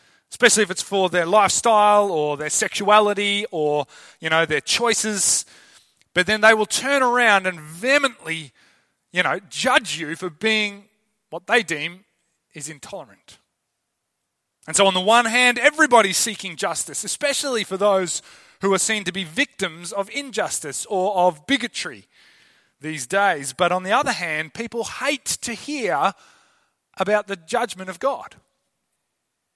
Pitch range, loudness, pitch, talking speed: 180-235 Hz, -20 LUFS, 205 Hz, 145 wpm